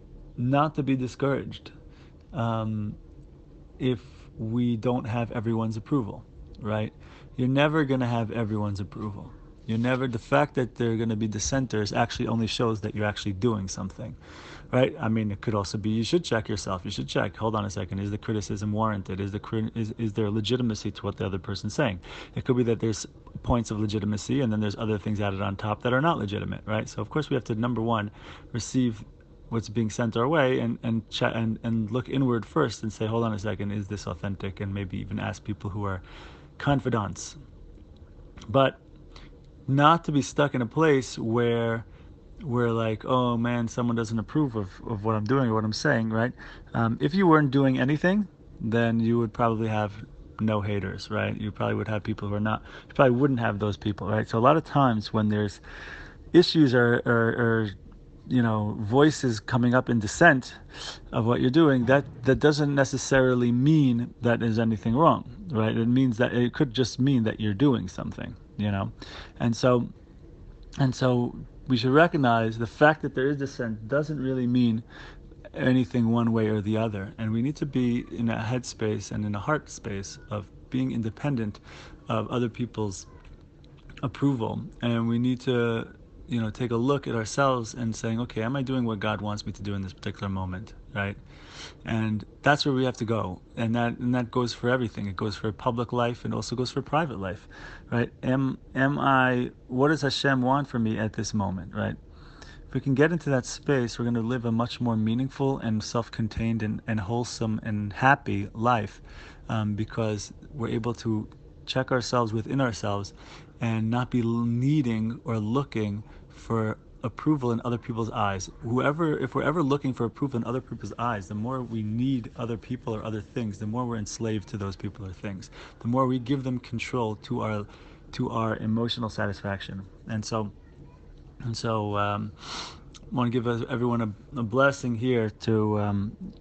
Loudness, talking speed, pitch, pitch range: -27 LUFS, 200 wpm, 115 Hz, 105-125 Hz